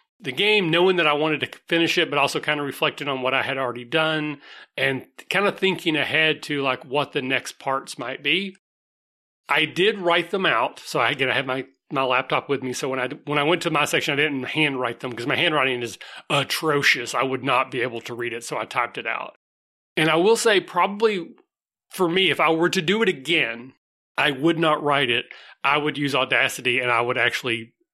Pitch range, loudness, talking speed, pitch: 130-170 Hz, -22 LUFS, 225 wpm, 145 Hz